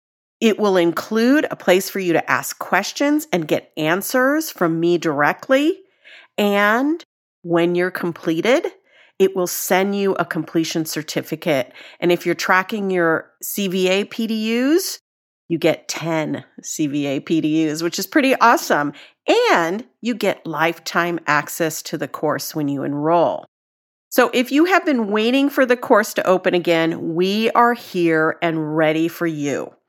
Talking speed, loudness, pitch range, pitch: 145 wpm, -19 LUFS, 165-230 Hz, 180 Hz